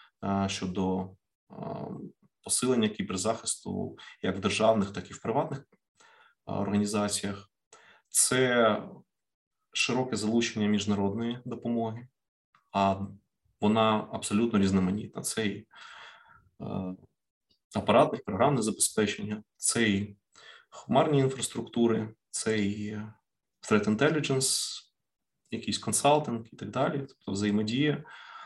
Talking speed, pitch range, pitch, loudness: 85 wpm, 100-120 Hz, 110 Hz, -29 LUFS